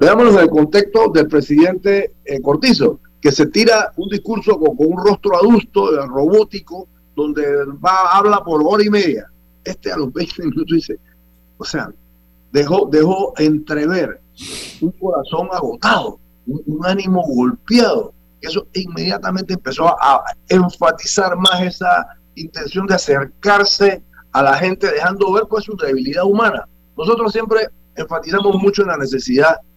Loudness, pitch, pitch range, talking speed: -15 LUFS, 180 Hz, 145-205 Hz, 145 wpm